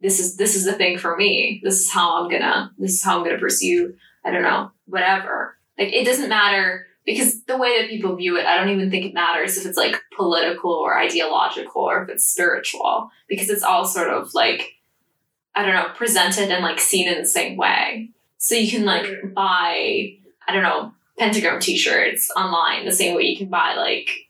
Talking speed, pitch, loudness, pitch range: 210 wpm, 195 Hz, -19 LUFS, 185-230 Hz